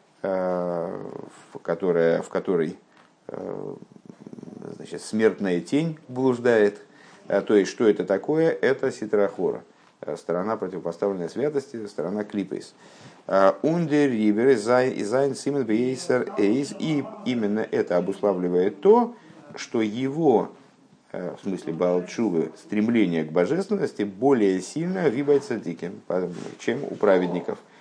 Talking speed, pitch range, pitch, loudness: 85 wpm, 100-150 Hz, 120 Hz, -24 LUFS